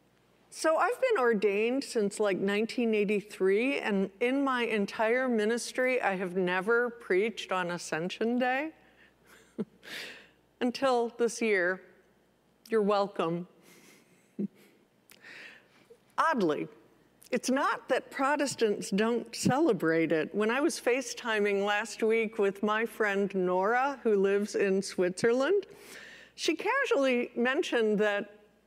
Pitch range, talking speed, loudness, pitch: 200-245 Hz, 105 wpm, -29 LUFS, 220 Hz